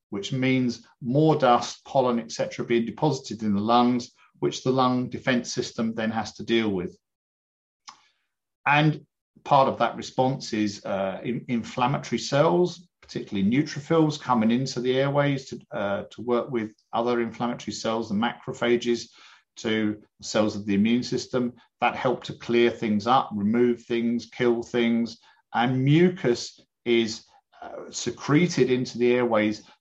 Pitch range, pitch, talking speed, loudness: 110-130 Hz, 120 Hz, 145 wpm, -25 LUFS